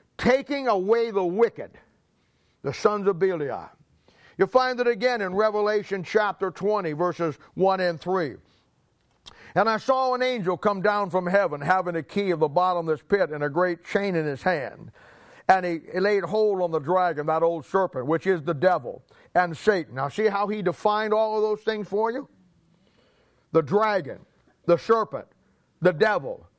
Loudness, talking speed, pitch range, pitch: -24 LUFS, 175 wpm, 175-215 Hz, 195 Hz